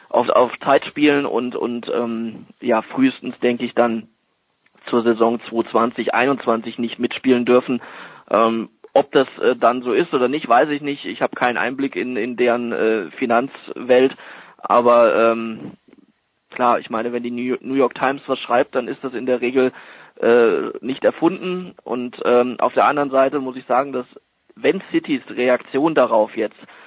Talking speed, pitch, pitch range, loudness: 175 wpm, 125 Hz, 120-135 Hz, -19 LUFS